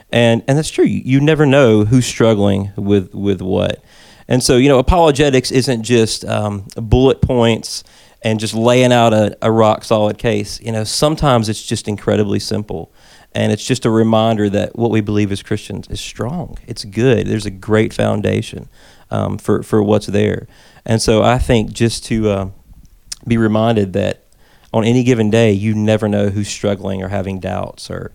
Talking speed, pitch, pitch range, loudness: 180 wpm, 110 Hz, 105-120 Hz, -15 LUFS